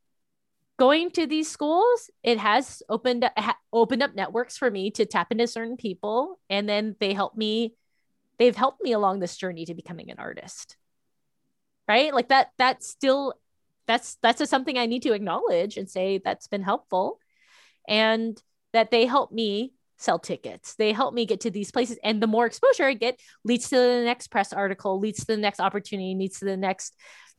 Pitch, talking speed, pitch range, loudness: 230 Hz, 190 wpm, 205-255 Hz, -25 LUFS